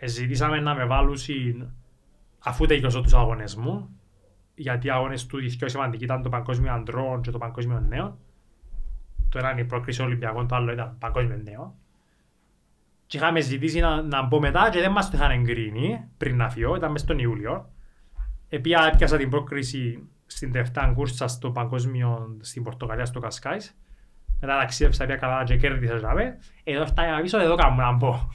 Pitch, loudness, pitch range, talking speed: 125 Hz, -25 LUFS, 115-140 Hz, 165 wpm